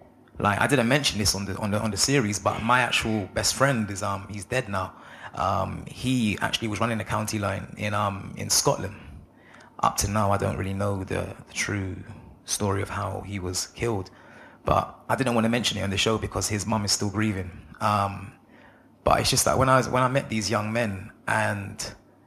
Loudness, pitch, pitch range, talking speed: -25 LUFS, 105 Hz, 100-115 Hz, 220 wpm